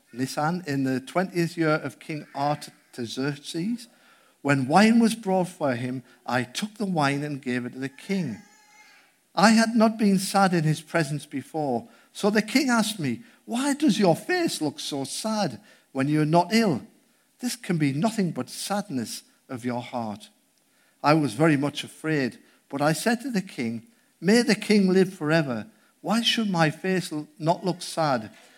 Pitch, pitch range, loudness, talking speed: 170 Hz, 145-220 Hz, -25 LUFS, 170 wpm